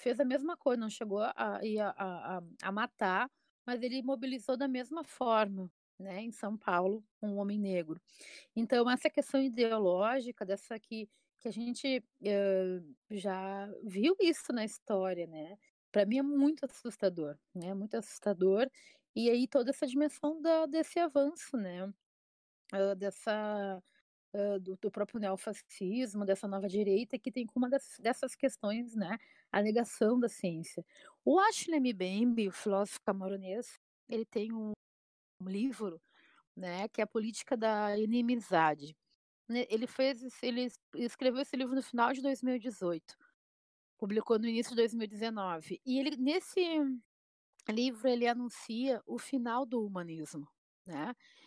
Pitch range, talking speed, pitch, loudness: 200-260 Hz, 140 wpm, 230 Hz, -35 LUFS